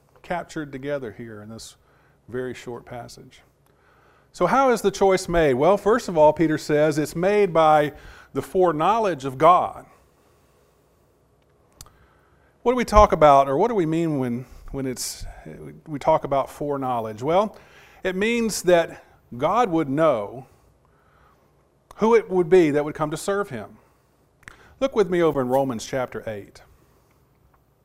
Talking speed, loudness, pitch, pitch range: 150 wpm, -21 LUFS, 150 Hz, 125-185 Hz